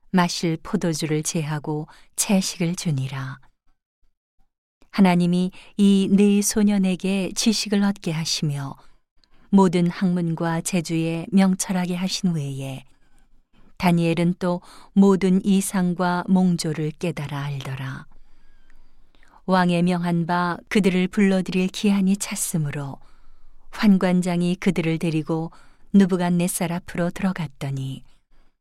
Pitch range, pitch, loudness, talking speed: 165-190 Hz, 180 Hz, -22 LUFS, 230 characters per minute